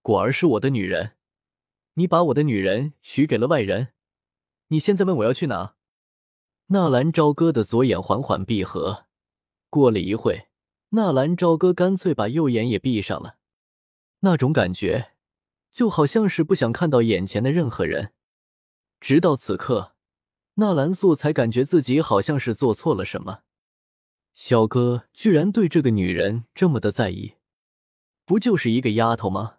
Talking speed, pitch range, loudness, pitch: 230 characters per minute, 110-170 Hz, -21 LUFS, 135 Hz